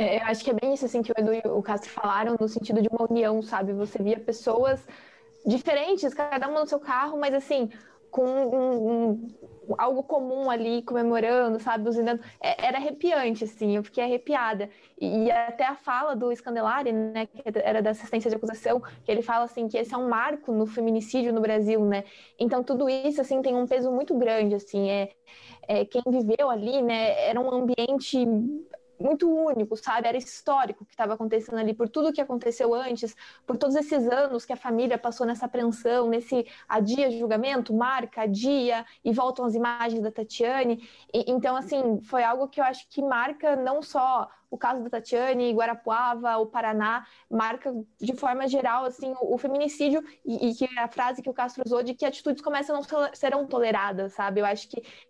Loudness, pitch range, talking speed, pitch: -27 LUFS, 225-265 Hz, 195 wpm, 245 Hz